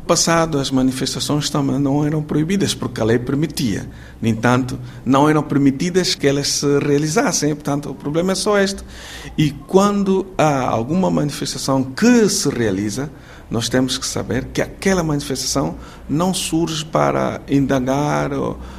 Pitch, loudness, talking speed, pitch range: 140 Hz, -18 LUFS, 145 wpm, 130-160 Hz